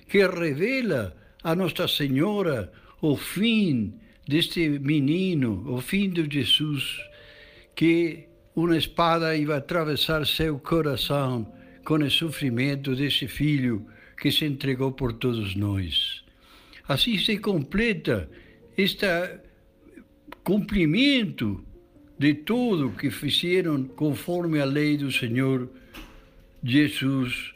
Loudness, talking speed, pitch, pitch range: -25 LUFS, 100 wpm, 150 Hz, 130-170 Hz